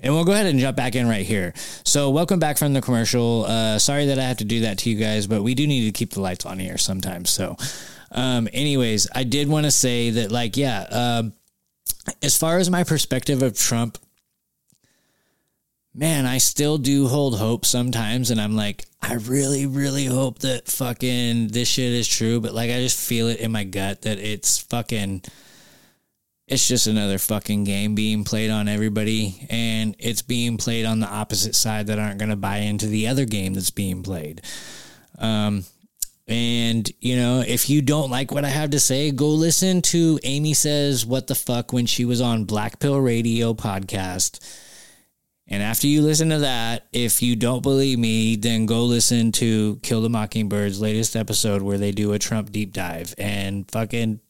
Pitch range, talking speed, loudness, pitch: 105-130 Hz, 195 wpm, -21 LUFS, 115 Hz